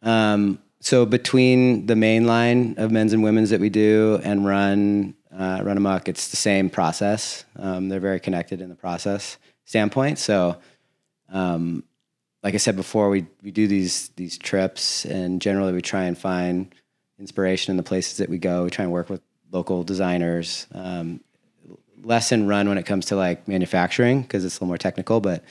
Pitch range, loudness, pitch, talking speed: 90-105 Hz, -22 LUFS, 95 Hz, 185 wpm